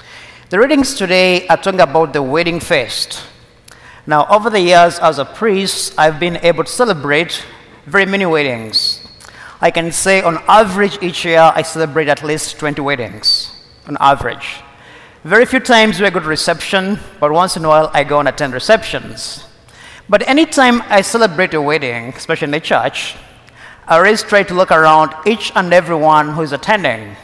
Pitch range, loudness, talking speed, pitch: 150-195 Hz, -12 LUFS, 170 wpm, 165 Hz